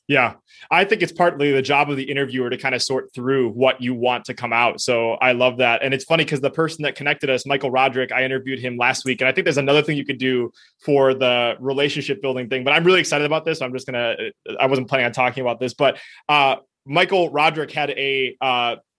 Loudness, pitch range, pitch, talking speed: -19 LUFS, 125-145 Hz, 135 Hz, 255 wpm